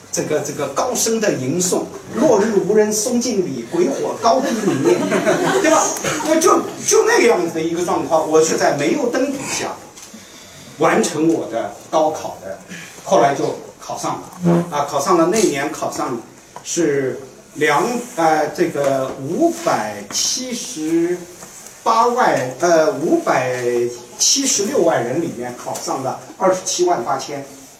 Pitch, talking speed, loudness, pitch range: 175 Hz, 205 characters per minute, -17 LUFS, 150-250 Hz